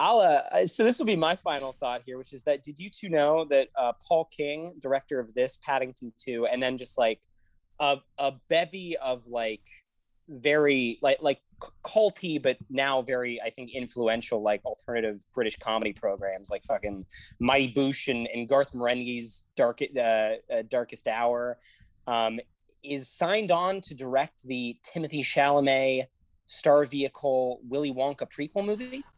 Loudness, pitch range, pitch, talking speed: -28 LUFS, 120-145 Hz, 130 Hz, 160 wpm